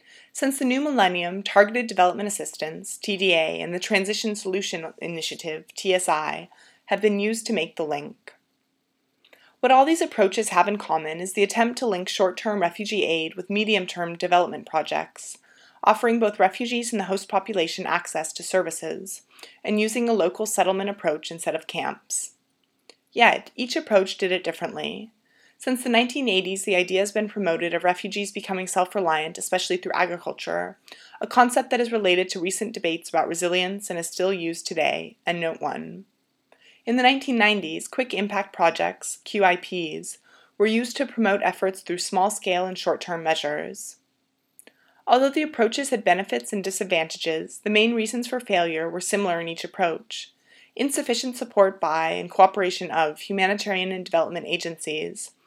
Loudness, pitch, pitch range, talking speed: -24 LUFS, 195 Hz, 175-220 Hz, 155 wpm